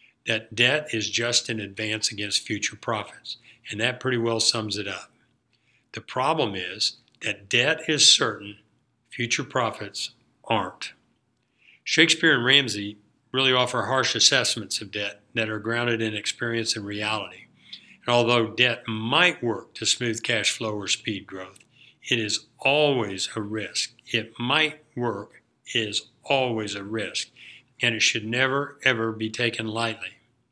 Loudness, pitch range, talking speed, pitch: -23 LUFS, 110-125 Hz, 145 wpm, 115 Hz